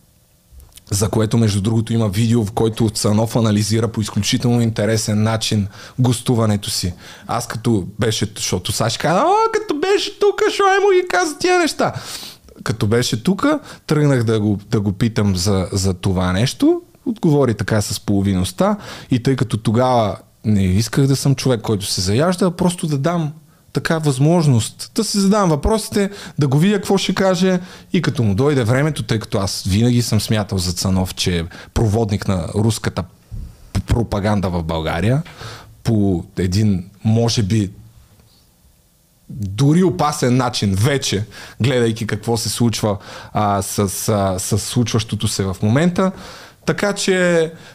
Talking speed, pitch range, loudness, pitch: 150 wpm, 105-150 Hz, -18 LUFS, 115 Hz